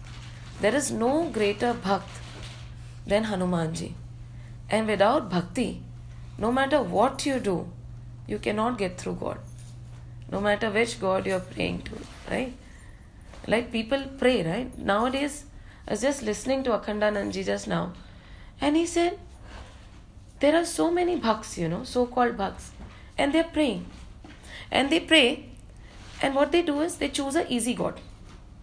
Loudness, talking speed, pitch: -26 LUFS, 155 wpm, 210 Hz